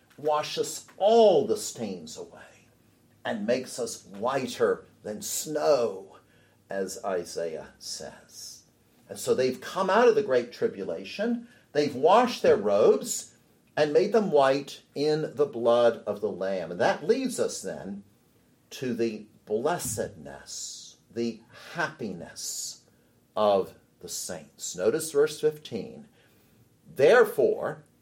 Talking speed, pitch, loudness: 115 wpm, 235 Hz, -27 LUFS